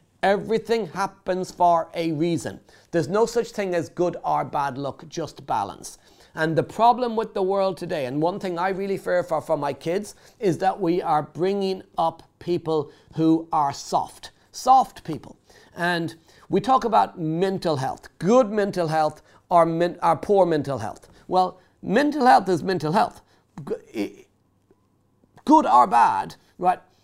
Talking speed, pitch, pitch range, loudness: 155 wpm, 180 Hz, 165-200 Hz, -23 LUFS